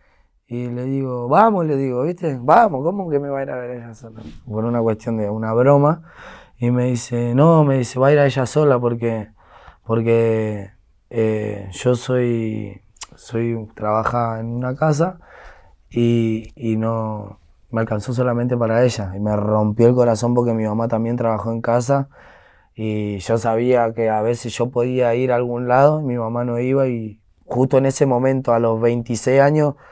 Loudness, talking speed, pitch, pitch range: -19 LUFS, 185 wpm, 120 Hz, 110-130 Hz